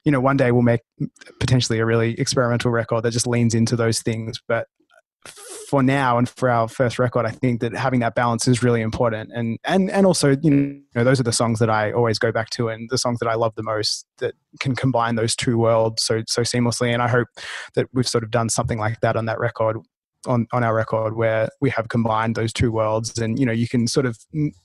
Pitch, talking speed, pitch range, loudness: 120 Hz, 245 wpm, 115-130 Hz, -21 LUFS